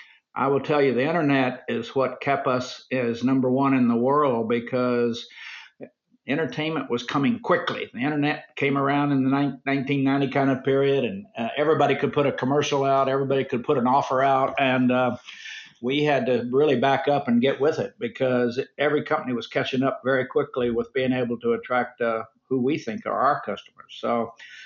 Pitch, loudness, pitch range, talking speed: 135 Hz, -23 LUFS, 125-140 Hz, 190 wpm